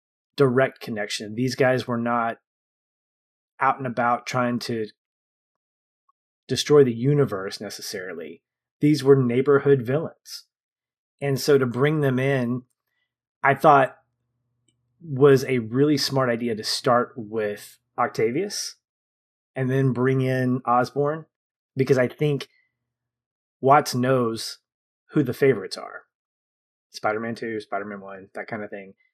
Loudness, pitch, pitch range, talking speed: -22 LUFS, 125 Hz, 115-135 Hz, 120 wpm